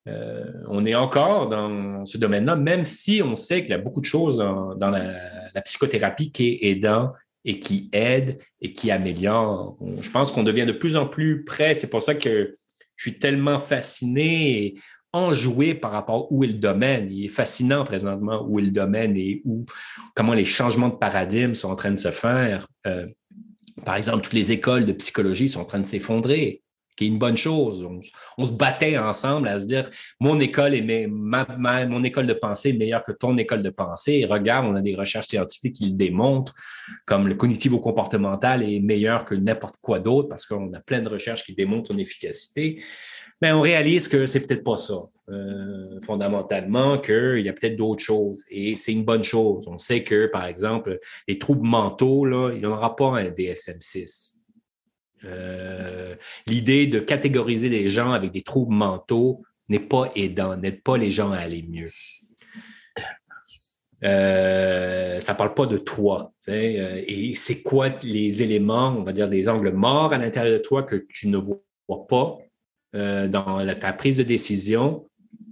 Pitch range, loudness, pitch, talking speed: 100-135 Hz, -22 LUFS, 115 Hz, 190 wpm